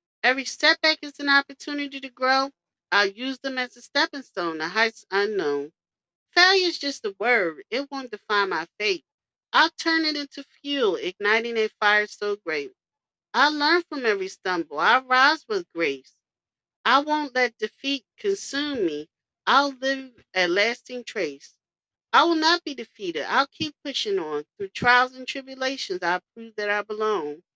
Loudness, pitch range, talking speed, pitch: -23 LUFS, 210-295 Hz, 165 wpm, 265 Hz